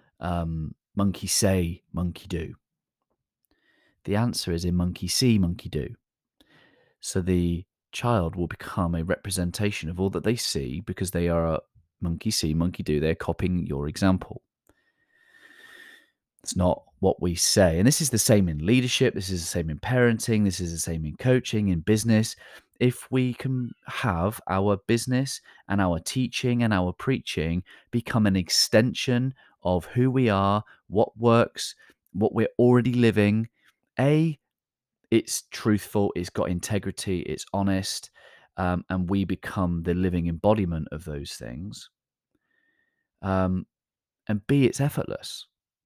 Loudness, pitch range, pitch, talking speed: -25 LUFS, 85-120 Hz, 95 Hz, 145 wpm